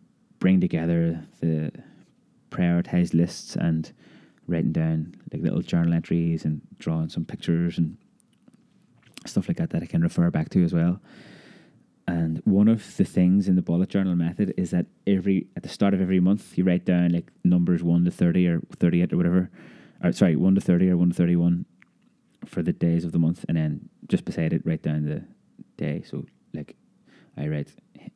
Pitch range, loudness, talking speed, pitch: 85-95 Hz, -24 LUFS, 190 wpm, 85 Hz